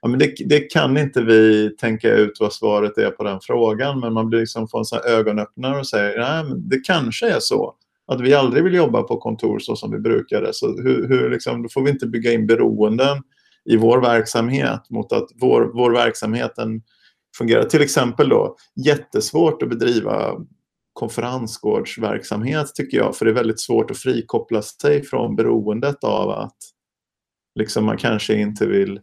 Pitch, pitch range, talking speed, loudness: 115 Hz, 110-140 Hz, 175 wpm, -19 LUFS